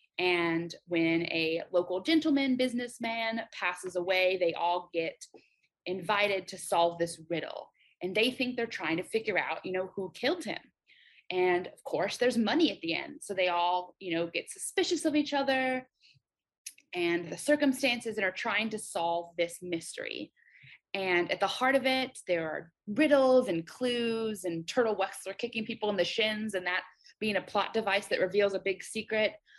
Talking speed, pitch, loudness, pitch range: 175 wpm, 205 Hz, -31 LUFS, 180-255 Hz